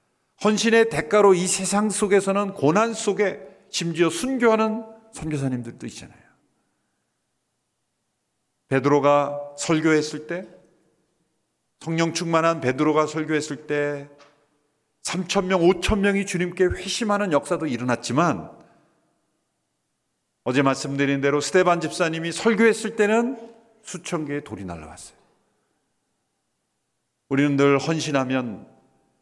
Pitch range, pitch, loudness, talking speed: 145-200 Hz, 165 Hz, -22 LUFS, 240 characters per minute